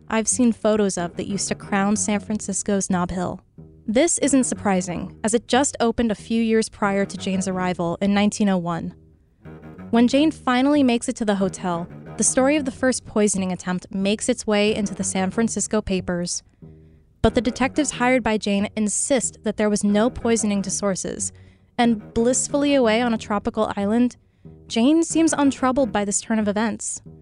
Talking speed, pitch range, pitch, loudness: 175 wpm, 190-240 Hz, 210 Hz, -21 LUFS